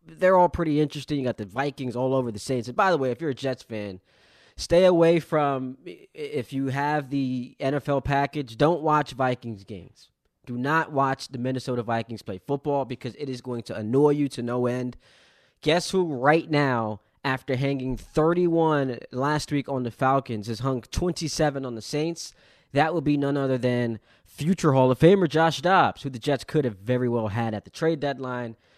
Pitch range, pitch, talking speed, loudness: 125-150 Hz, 135 Hz, 195 wpm, -25 LUFS